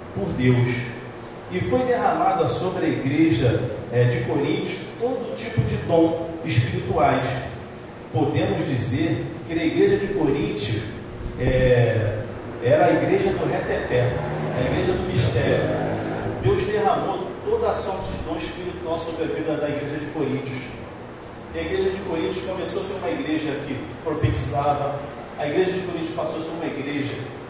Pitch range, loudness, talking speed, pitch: 120-160 Hz, -22 LUFS, 150 wpm, 140 Hz